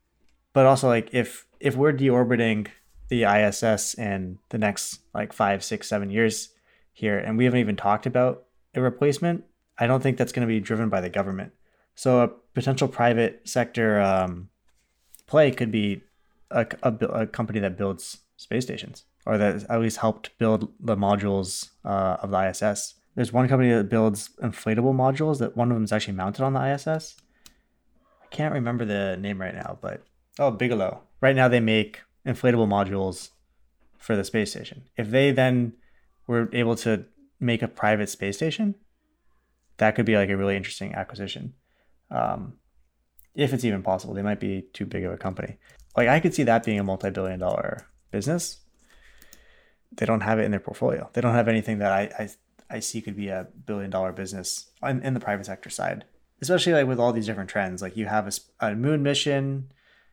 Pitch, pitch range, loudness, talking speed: 110 Hz, 100-125 Hz, -25 LUFS, 185 wpm